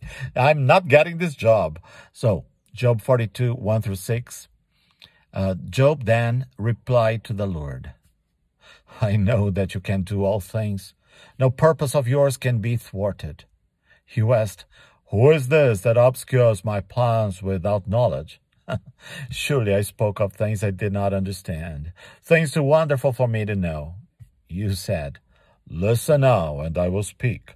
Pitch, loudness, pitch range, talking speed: 110 Hz, -21 LUFS, 100-130 Hz, 150 wpm